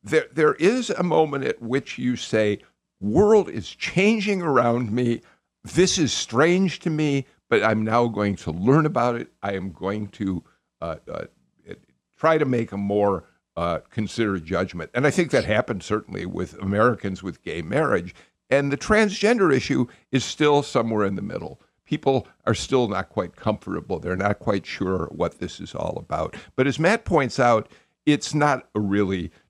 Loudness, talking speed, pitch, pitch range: -23 LUFS, 175 wpm, 120 Hz, 100-150 Hz